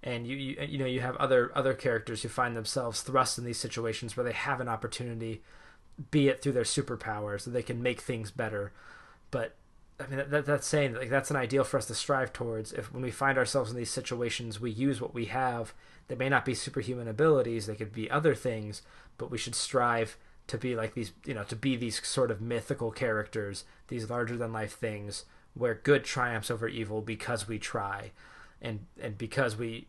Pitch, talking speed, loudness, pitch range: 120 Hz, 215 wpm, -32 LUFS, 115-135 Hz